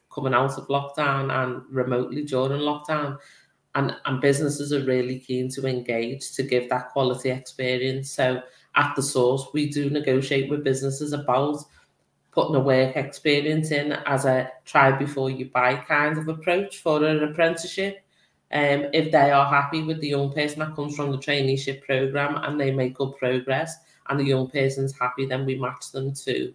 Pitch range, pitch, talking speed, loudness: 130-145 Hz, 135 Hz, 180 wpm, -24 LUFS